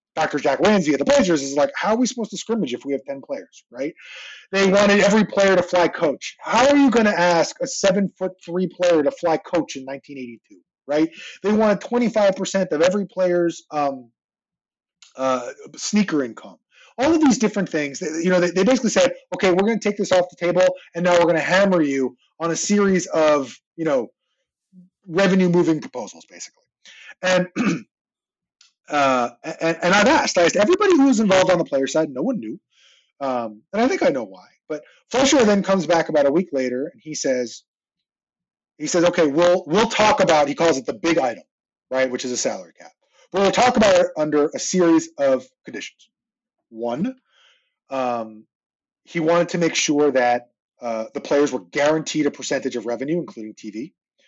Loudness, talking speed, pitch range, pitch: -19 LUFS, 200 wpm, 145-210 Hz, 175 Hz